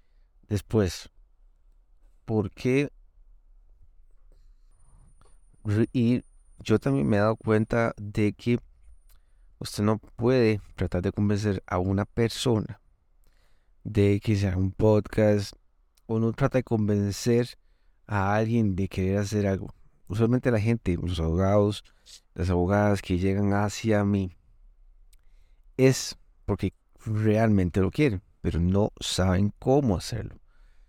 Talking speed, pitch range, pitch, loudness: 115 wpm, 85-110 Hz, 100 Hz, -26 LUFS